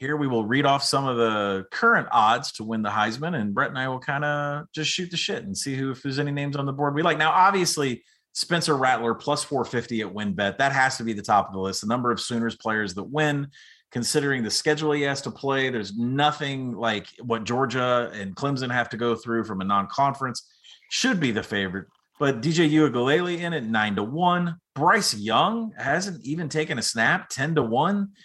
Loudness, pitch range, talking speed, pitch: -24 LUFS, 115-150 Hz, 225 wpm, 135 Hz